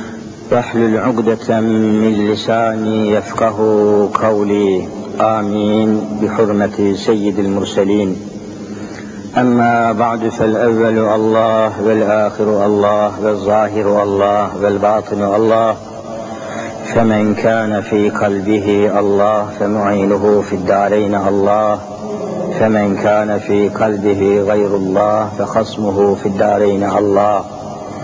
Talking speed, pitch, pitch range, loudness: 85 wpm, 105 Hz, 100-110 Hz, -14 LUFS